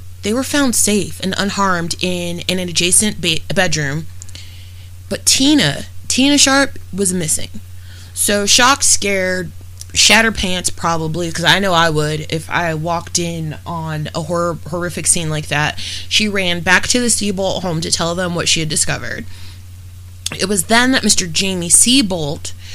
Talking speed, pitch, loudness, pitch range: 160 wpm, 170 Hz, -14 LUFS, 145-195 Hz